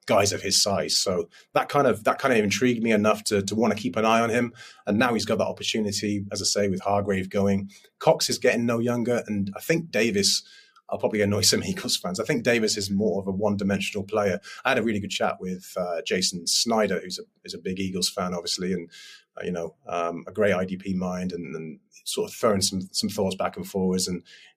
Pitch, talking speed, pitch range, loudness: 100 Hz, 240 wpm, 95-115 Hz, -25 LUFS